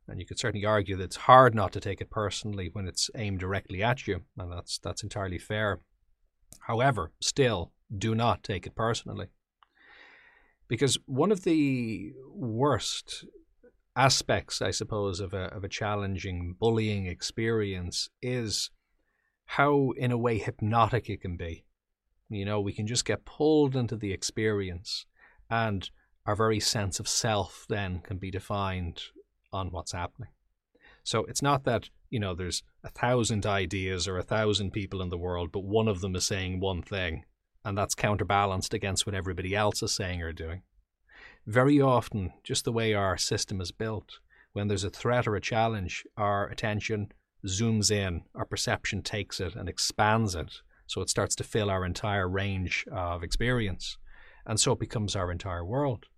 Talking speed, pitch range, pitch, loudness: 170 wpm, 95-115 Hz, 105 Hz, -29 LUFS